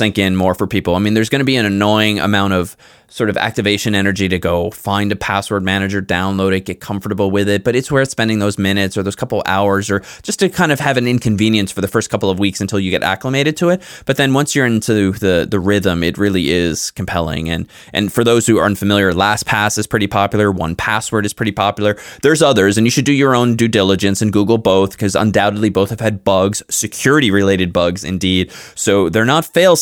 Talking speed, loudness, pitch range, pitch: 230 wpm, -15 LUFS, 95-110 Hz, 100 Hz